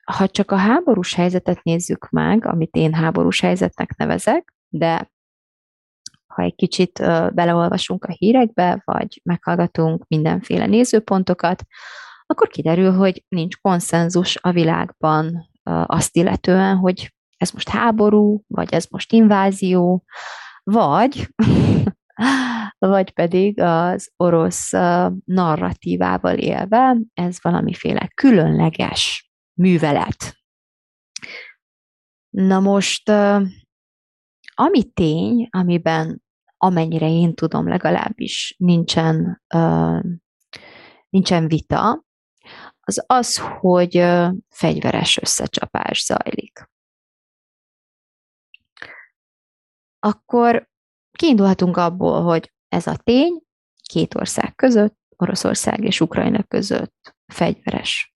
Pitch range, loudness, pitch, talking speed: 165-210 Hz, -18 LUFS, 180 Hz, 85 wpm